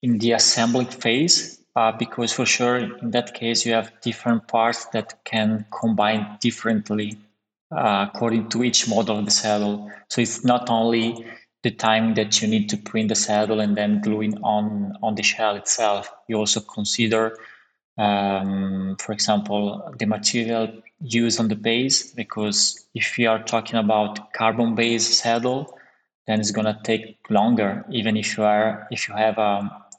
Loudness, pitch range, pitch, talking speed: -21 LUFS, 105-115 Hz, 110 Hz, 165 wpm